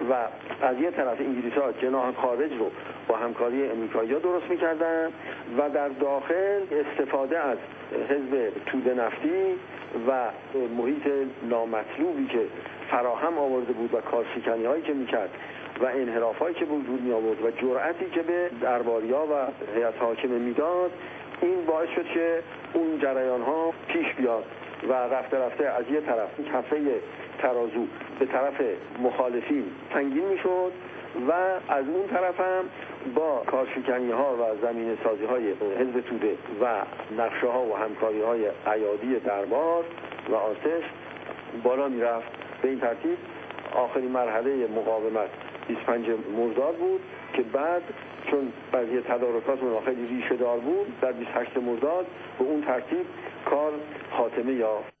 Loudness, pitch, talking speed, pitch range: -27 LUFS, 135 Hz, 140 wpm, 120-170 Hz